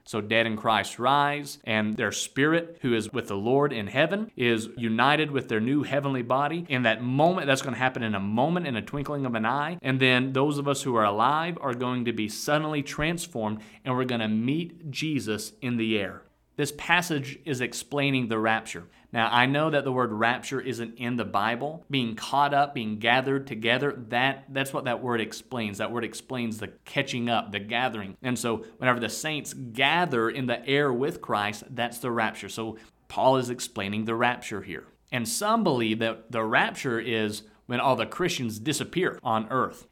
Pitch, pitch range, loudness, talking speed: 125 Hz, 110-140 Hz, -27 LUFS, 195 wpm